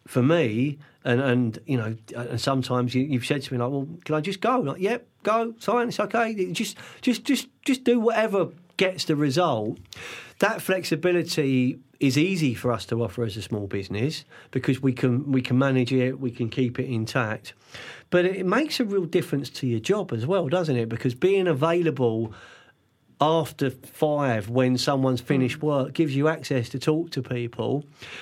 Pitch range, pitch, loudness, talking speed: 125-180 Hz, 140 Hz, -25 LUFS, 185 wpm